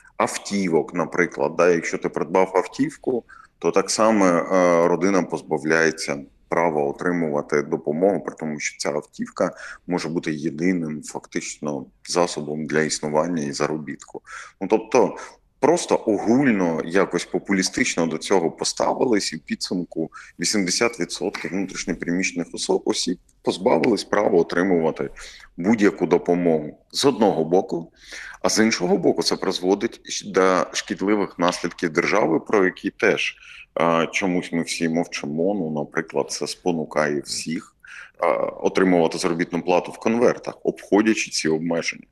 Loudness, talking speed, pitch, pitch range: -22 LUFS, 120 wpm, 85 Hz, 80-95 Hz